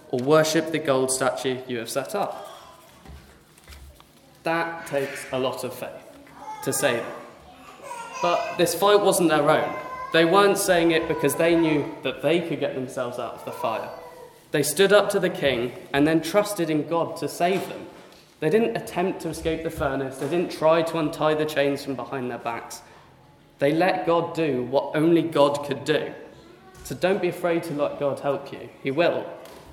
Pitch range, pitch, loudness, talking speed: 140-170 Hz, 155 Hz, -23 LUFS, 185 wpm